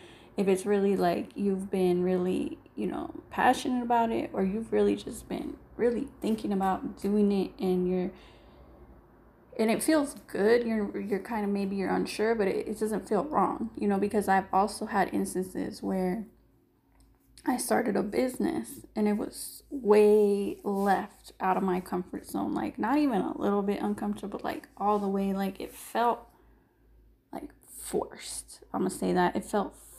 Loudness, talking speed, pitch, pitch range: -29 LUFS, 170 wpm, 205 Hz, 190-225 Hz